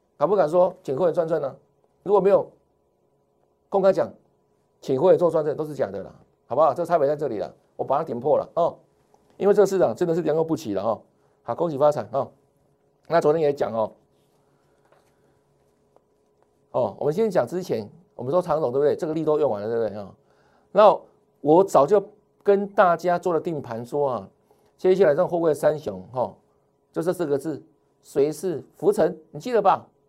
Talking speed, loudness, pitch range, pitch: 265 characters per minute, -23 LUFS, 145-195 Hz, 170 Hz